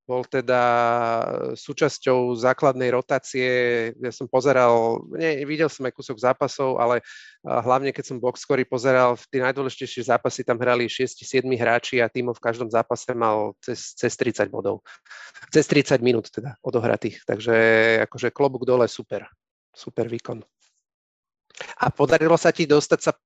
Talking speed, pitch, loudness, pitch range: 145 wpm, 125 Hz, -22 LUFS, 120-130 Hz